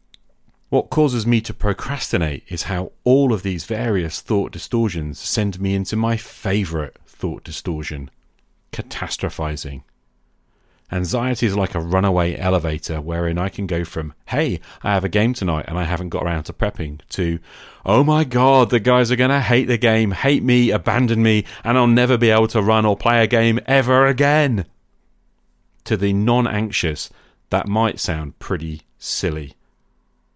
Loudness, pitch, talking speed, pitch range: -19 LUFS, 100 Hz, 160 wpm, 85-120 Hz